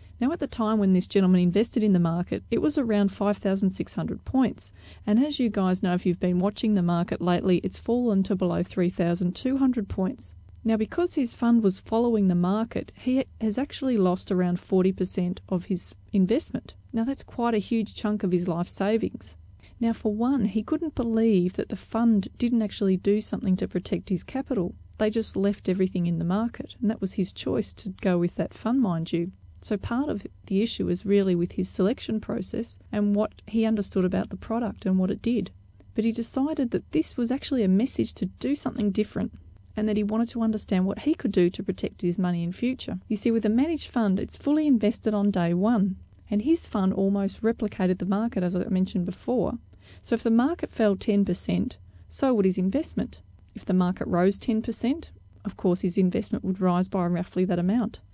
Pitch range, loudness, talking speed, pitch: 185-230 Hz, -26 LUFS, 205 wpm, 205 Hz